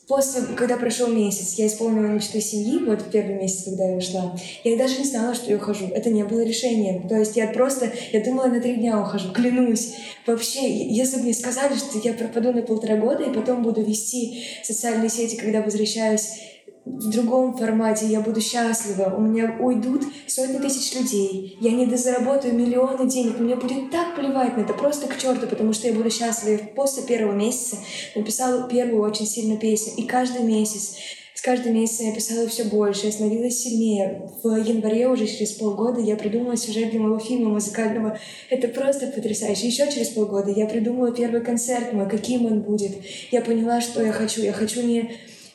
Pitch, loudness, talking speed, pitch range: 230 Hz, -22 LUFS, 190 wpm, 215-245 Hz